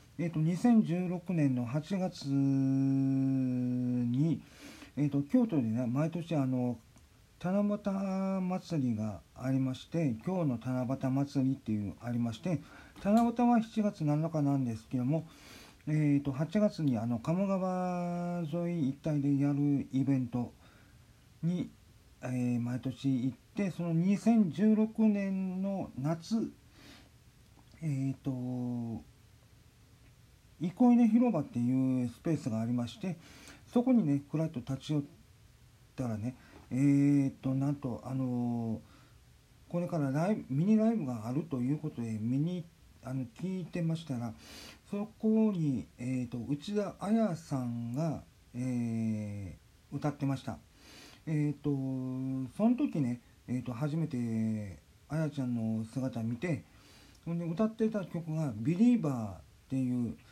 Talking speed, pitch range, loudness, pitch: 230 characters per minute, 120-170 Hz, -33 LUFS, 140 Hz